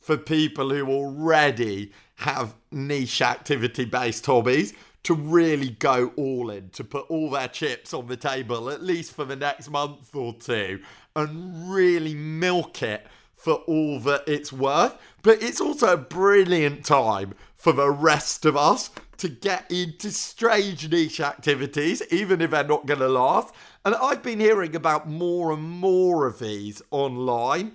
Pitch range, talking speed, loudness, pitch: 135-170 Hz, 160 wpm, -23 LUFS, 150 Hz